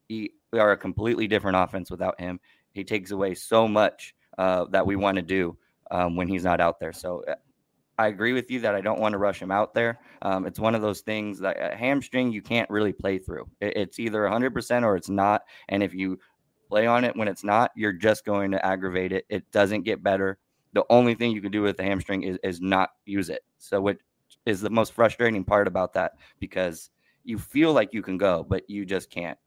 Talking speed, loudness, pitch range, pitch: 225 wpm, -25 LUFS, 95-110 Hz, 100 Hz